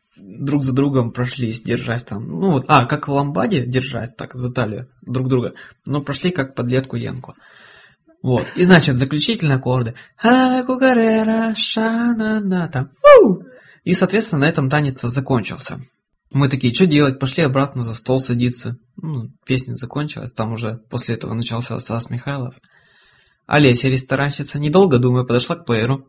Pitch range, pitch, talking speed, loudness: 125-150 Hz, 135 Hz, 140 wpm, -18 LUFS